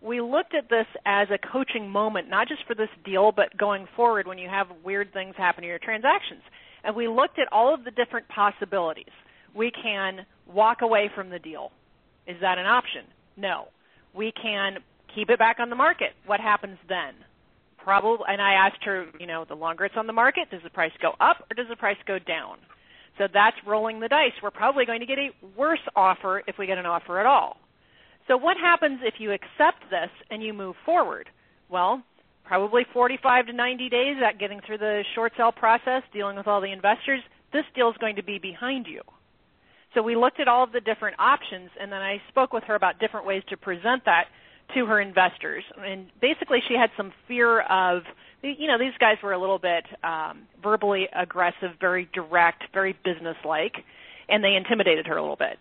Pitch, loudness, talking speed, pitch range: 205 Hz, -24 LUFS, 205 wpm, 190-235 Hz